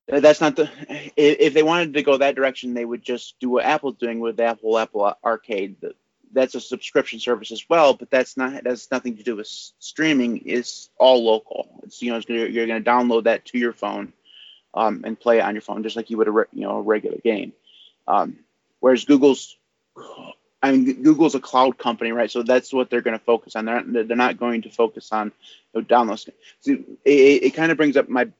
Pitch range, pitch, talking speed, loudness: 115-135 Hz, 120 Hz, 225 wpm, -20 LUFS